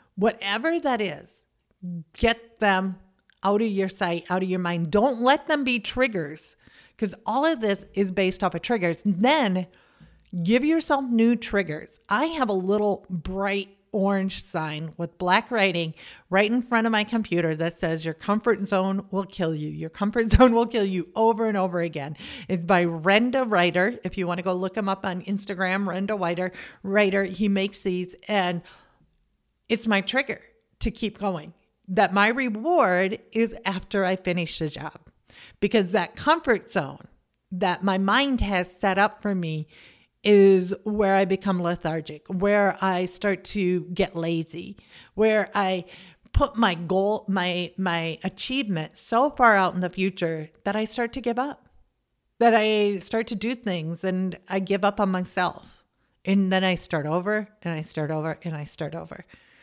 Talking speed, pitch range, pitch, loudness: 170 wpm, 180-215 Hz, 195 Hz, -24 LUFS